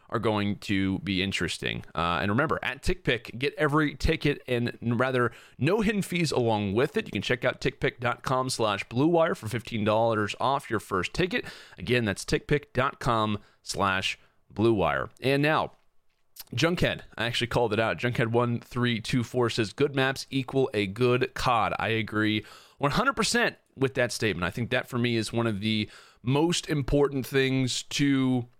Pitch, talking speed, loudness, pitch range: 120 Hz, 160 wpm, -27 LUFS, 110-140 Hz